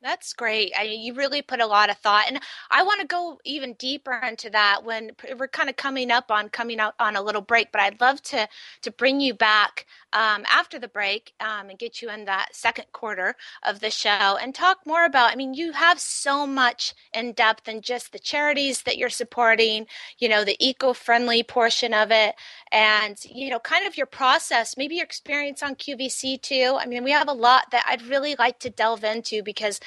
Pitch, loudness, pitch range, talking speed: 240 Hz, -22 LUFS, 215-270 Hz, 220 wpm